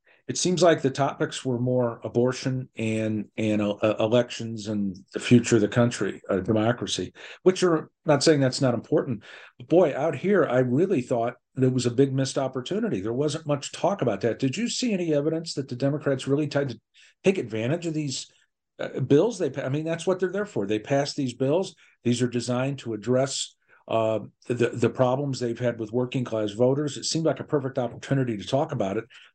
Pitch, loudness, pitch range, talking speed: 130 Hz, -25 LUFS, 115-150 Hz, 205 wpm